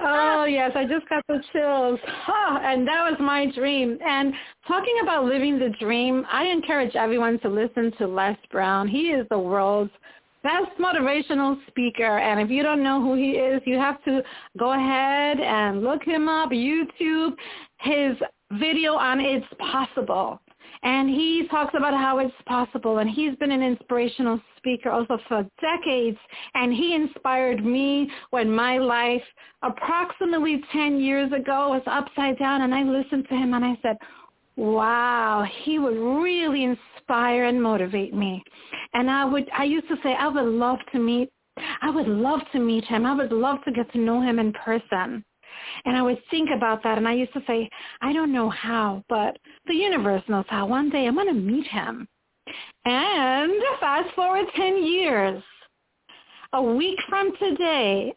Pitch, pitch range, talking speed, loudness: 265 Hz, 235-295 Hz, 170 wpm, -23 LUFS